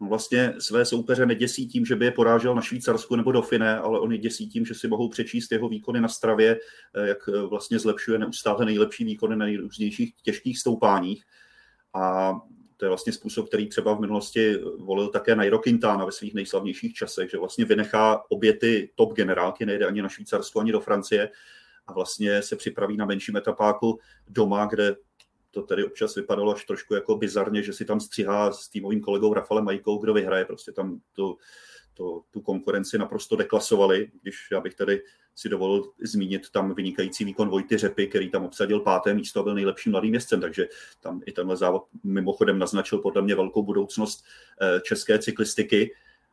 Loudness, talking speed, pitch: -25 LUFS, 180 wpm, 115 Hz